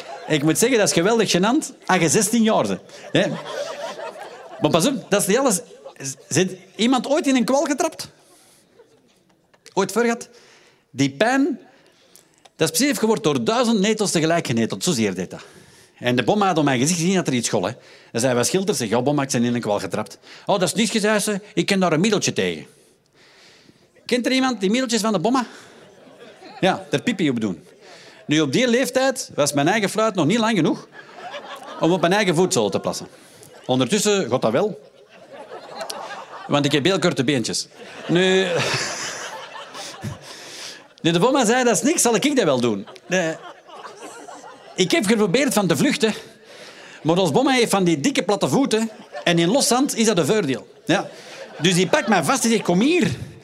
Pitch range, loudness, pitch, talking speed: 165-235 Hz, -20 LUFS, 200 Hz, 185 wpm